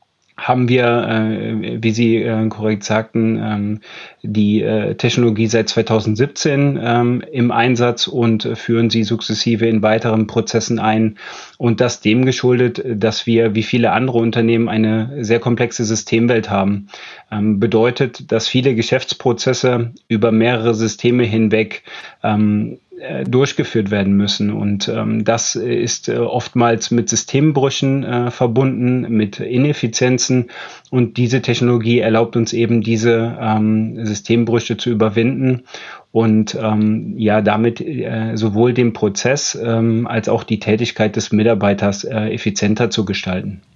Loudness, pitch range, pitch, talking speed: -16 LUFS, 110-120 Hz, 115 Hz, 120 wpm